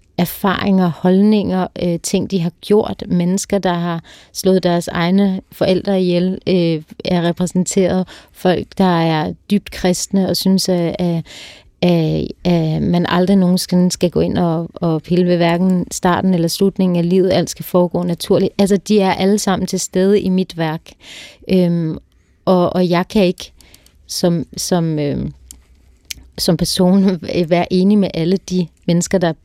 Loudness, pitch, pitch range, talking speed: -16 LUFS, 180 Hz, 170-190 Hz, 160 wpm